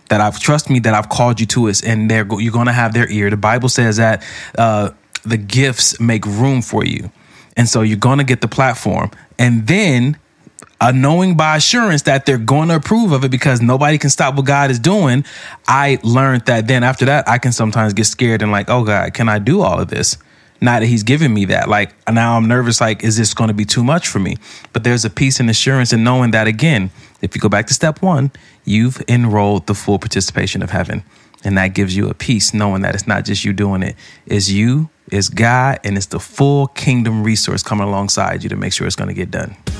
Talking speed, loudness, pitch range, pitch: 240 wpm, -14 LUFS, 105-135 Hz, 115 Hz